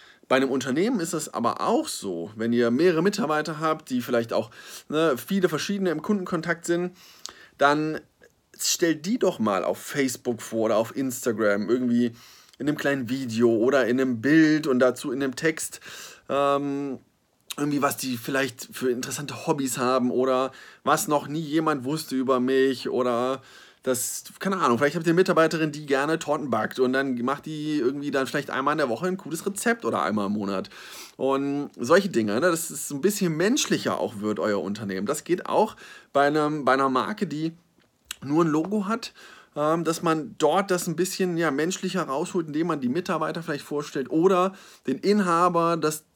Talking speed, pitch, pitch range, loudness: 180 wpm, 145 Hz, 130-165 Hz, -25 LUFS